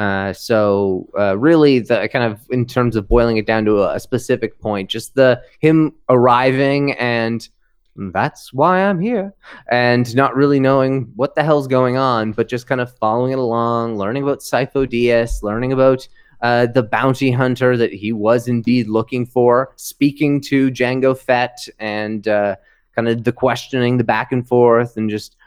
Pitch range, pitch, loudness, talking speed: 115-130 Hz, 125 Hz, -16 LUFS, 175 wpm